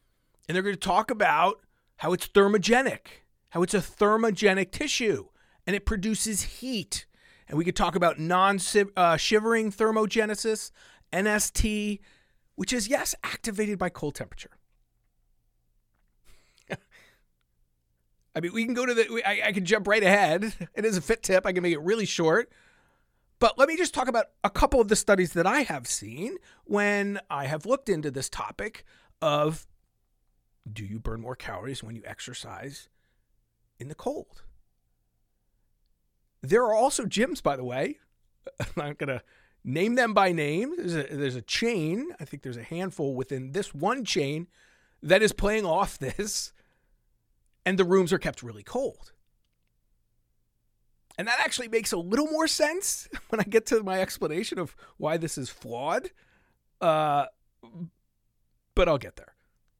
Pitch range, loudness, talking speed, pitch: 150-220 Hz, -26 LUFS, 160 wpm, 195 Hz